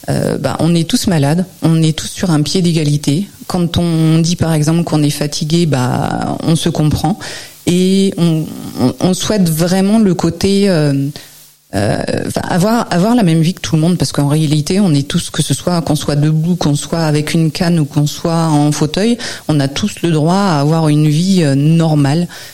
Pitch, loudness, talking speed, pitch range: 160 Hz, -13 LUFS, 200 wpm, 150-175 Hz